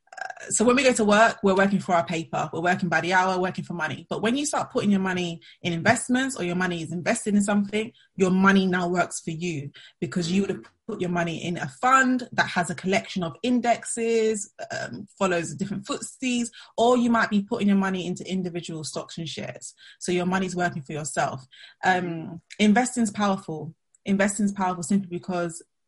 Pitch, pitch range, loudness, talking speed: 190 Hz, 175-220 Hz, -24 LUFS, 205 wpm